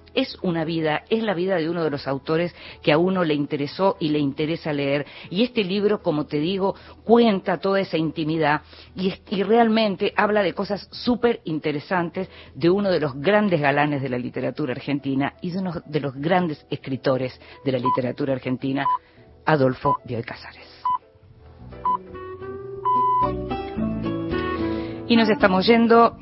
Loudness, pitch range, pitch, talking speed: -23 LUFS, 145-210 Hz, 170 Hz, 155 wpm